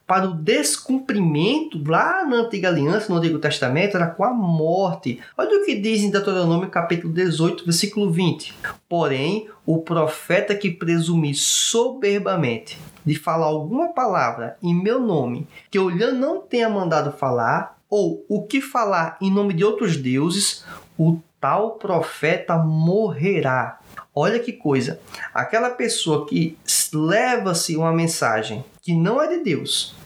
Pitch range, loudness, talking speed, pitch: 160-215 Hz, -21 LUFS, 140 wpm, 180 Hz